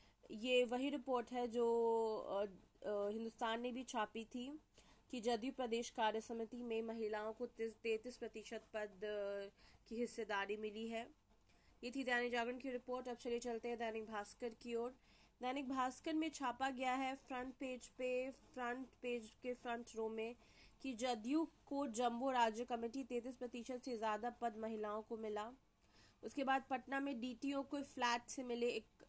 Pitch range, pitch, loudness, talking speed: 225-255 Hz, 240 Hz, -44 LUFS, 160 wpm